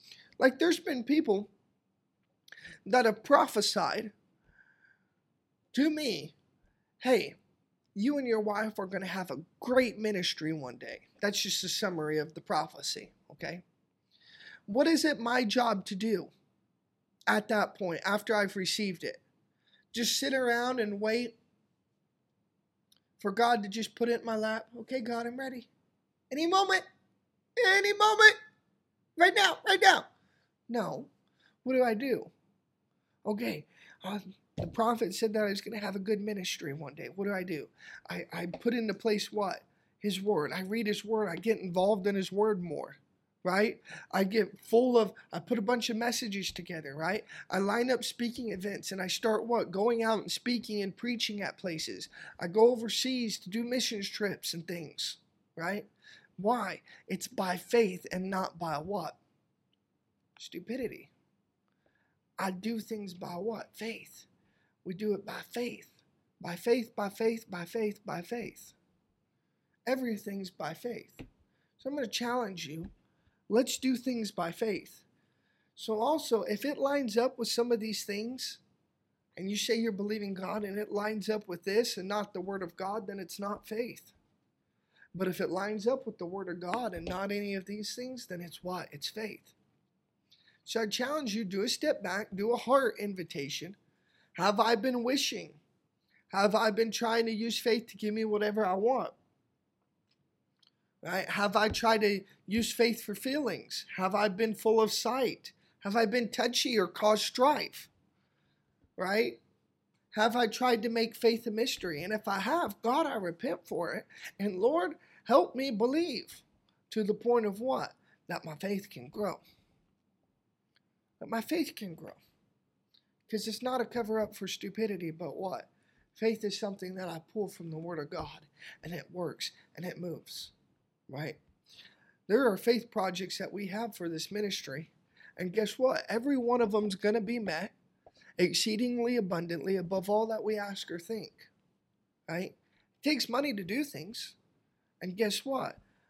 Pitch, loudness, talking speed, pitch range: 215 Hz, -32 LUFS, 165 wpm, 190-235 Hz